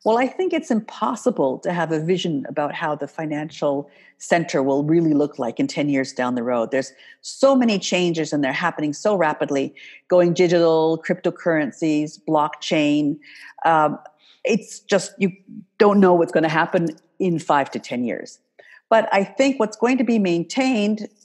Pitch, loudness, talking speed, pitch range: 170 Hz, -20 LUFS, 170 wpm, 150-210 Hz